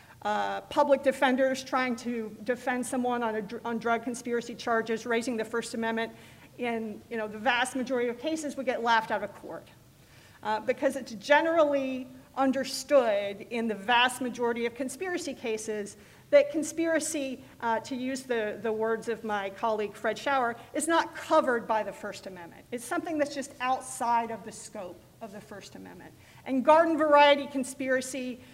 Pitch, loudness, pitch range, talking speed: 245 Hz, -28 LUFS, 225-270 Hz, 165 wpm